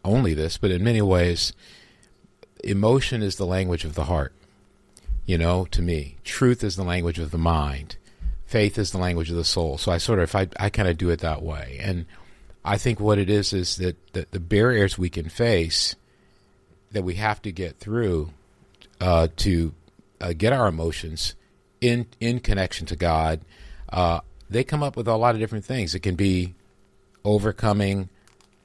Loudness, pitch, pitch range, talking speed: -24 LUFS, 95 Hz, 85-105 Hz, 185 wpm